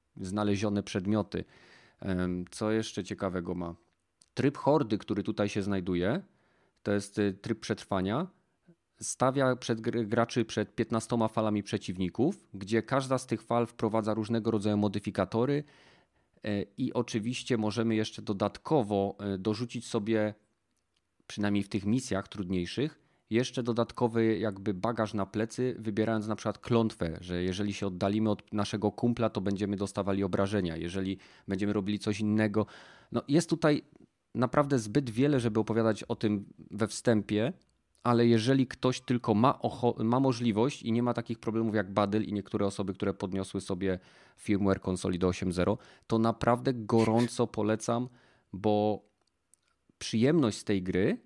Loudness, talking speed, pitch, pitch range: -31 LUFS, 135 wpm, 110 Hz, 100-120 Hz